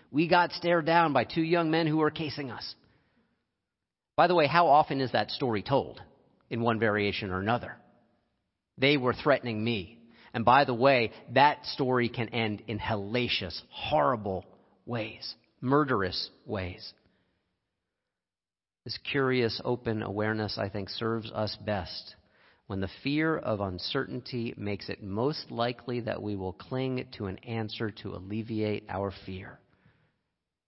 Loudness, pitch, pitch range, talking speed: -29 LUFS, 115 Hz, 100-130 Hz, 145 wpm